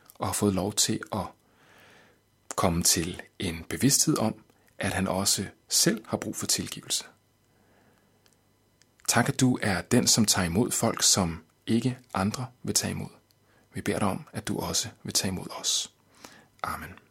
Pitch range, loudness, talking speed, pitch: 95-120 Hz, -26 LUFS, 160 wpm, 105 Hz